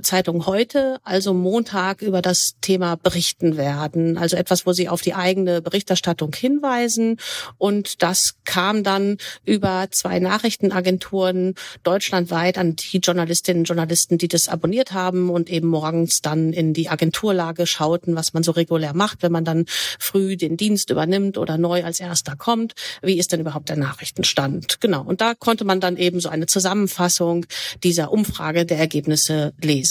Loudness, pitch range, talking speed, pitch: -20 LUFS, 165-190 Hz, 165 wpm, 180 Hz